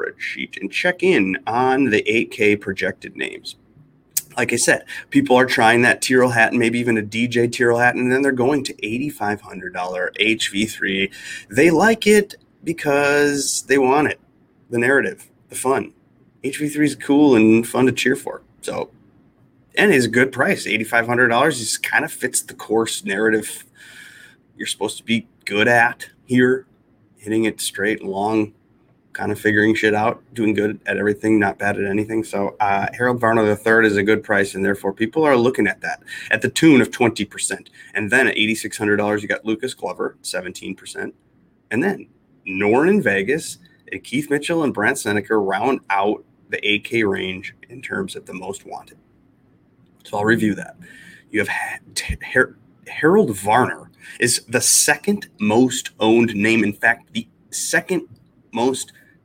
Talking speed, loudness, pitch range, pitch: 165 wpm, -18 LUFS, 105-130 Hz, 115 Hz